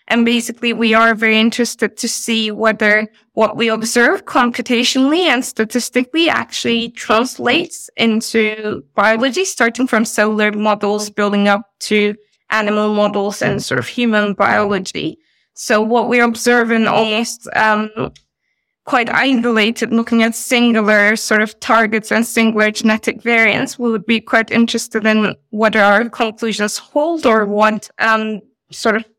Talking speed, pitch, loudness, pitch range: 140 wpm, 225 Hz, -14 LUFS, 215-235 Hz